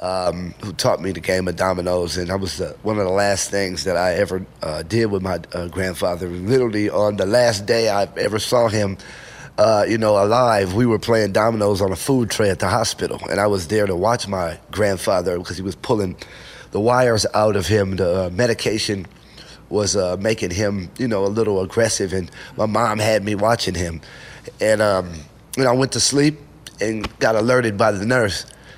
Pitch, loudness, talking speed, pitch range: 100 Hz, -19 LUFS, 205 wpm, 95-110 Hz